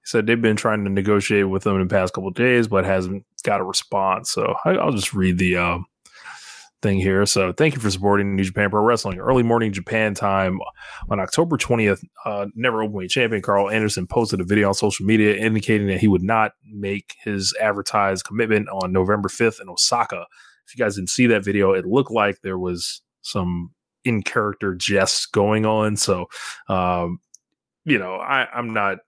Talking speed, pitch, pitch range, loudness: 200 wpm, 100 Hz, 95-110 Hz, -20 LUFS